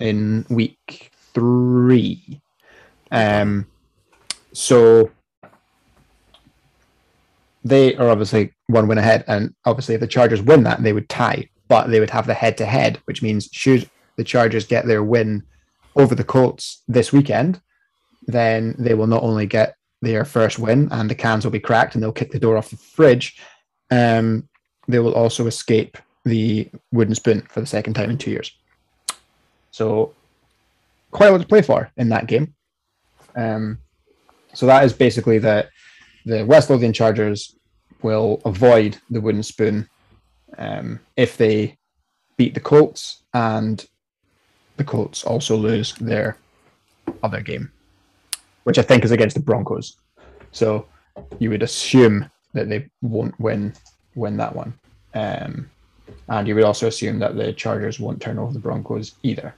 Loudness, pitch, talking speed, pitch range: -18 LUFS, 115 Hz, 155 wpm, 110-125 Hz